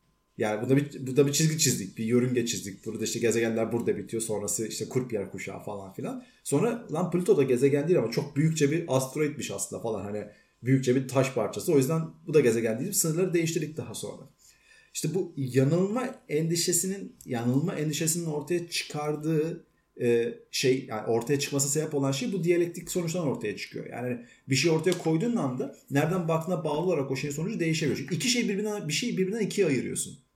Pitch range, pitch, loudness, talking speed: 125-170 Hz, 145 Hz, -28 LUFS, 190 wpm